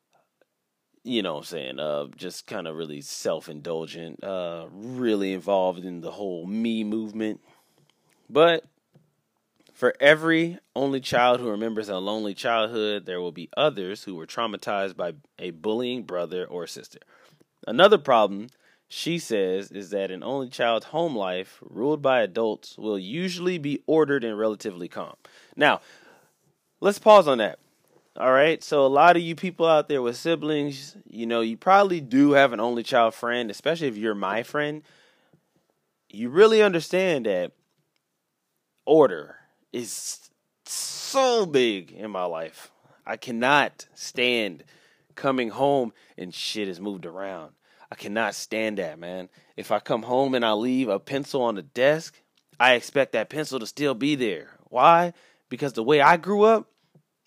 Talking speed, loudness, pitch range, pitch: 155 wpm, -24 LUFS, 105-155 Hz, 125 Hz